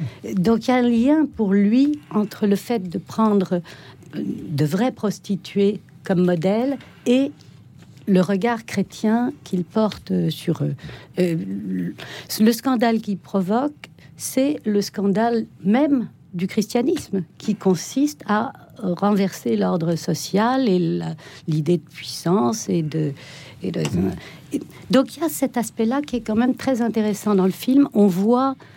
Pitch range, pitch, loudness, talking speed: 175-235 Hz, 200 Hz, -21 LUFS, 140 wpm